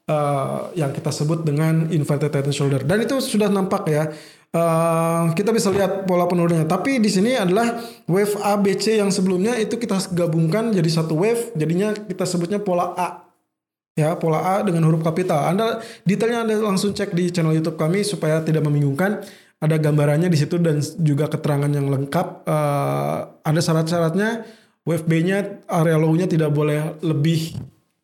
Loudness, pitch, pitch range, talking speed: -20 LUFS, 170 Hz, 155-200 Hz, 160 wpm